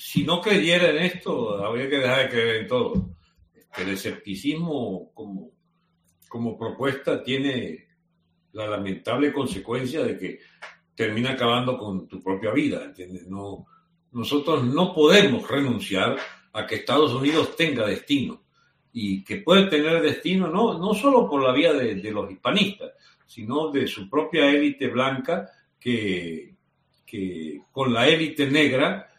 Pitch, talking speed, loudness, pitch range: 135 Hz, 140 wpm, -23 LUFS, 105-165 Hz